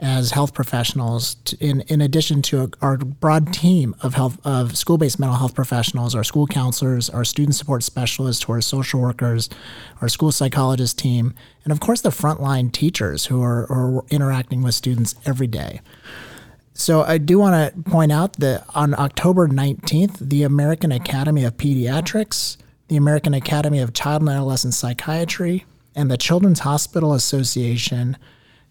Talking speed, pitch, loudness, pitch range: 155 wpm, 135 Hz, -19 LUFS, 125-150 Hz